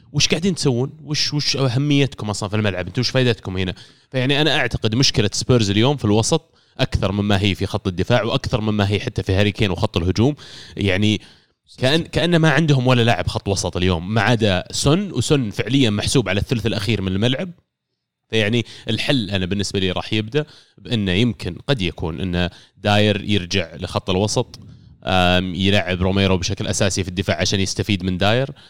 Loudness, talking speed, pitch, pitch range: -19 LUFS, 170 wpm, 110 Hz, 100-130 Hz